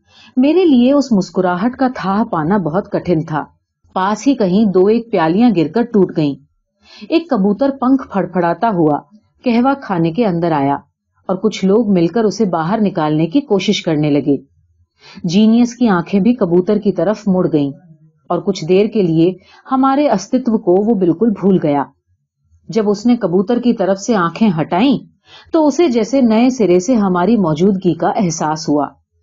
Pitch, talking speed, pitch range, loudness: 195 Hz, 170 wpm, 165-230 Hz, -14 LUFS